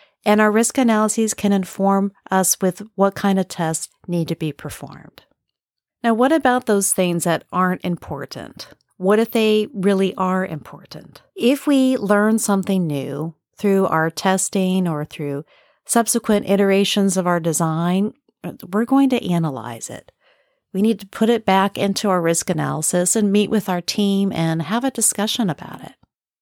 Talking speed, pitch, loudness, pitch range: 160 wpm, 195 Hz, -19 LUFS, 175-215 Hz